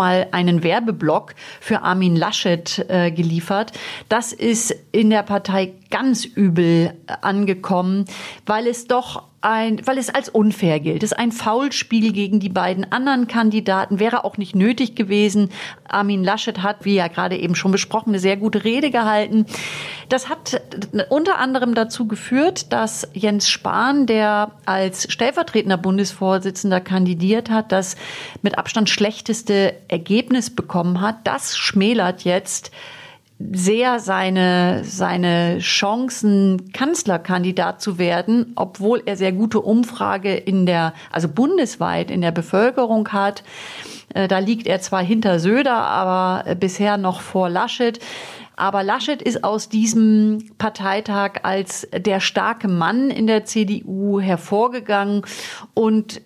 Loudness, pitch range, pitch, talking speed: -19 LUFS, 190-225 Hz, 205 Hz, 130 wpm